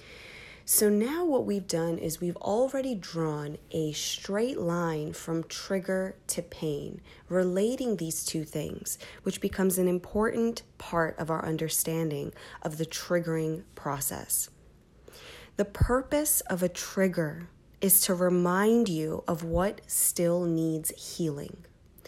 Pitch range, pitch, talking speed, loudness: 160-205 Hz, 175 Hz, 125 wpm, -29 LUFS